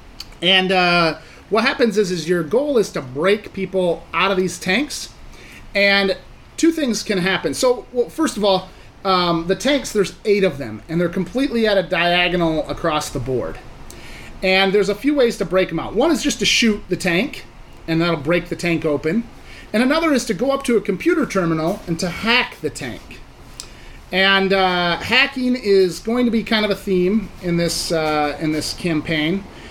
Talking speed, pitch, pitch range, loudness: 195 wpm, 190 Hz, 170-225 Hz, -18 LUFS